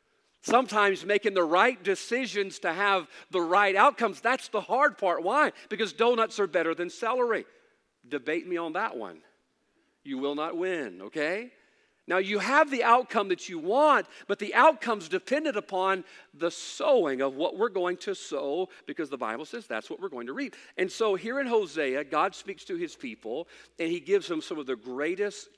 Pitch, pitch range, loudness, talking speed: 220 Hz, 185-300 Hz, -28 LUFS, 190 wpm